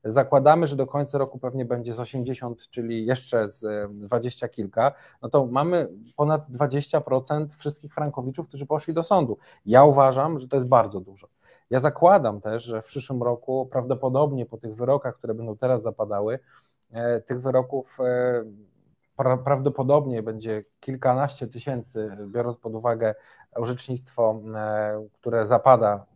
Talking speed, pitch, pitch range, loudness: 135 wpm, 125 Hz, 115-140 Hz, -24 LUFS